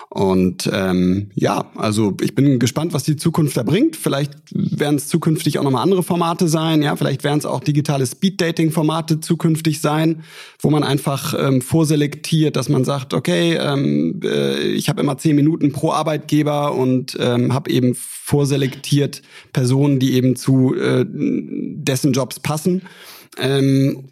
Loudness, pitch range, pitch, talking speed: -18 LUFS, 135-160 Hz, 145 Hz, 155 wpm